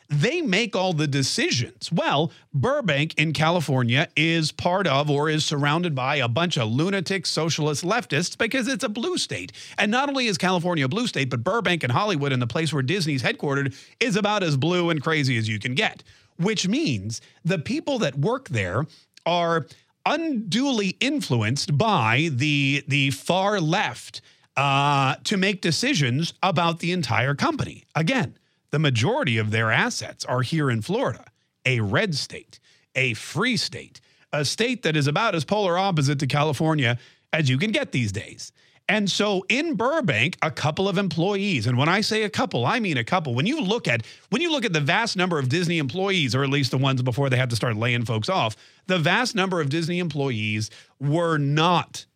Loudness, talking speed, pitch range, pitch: -23 LUFS, 190 wpm, 135-185 Hz, 155 Hz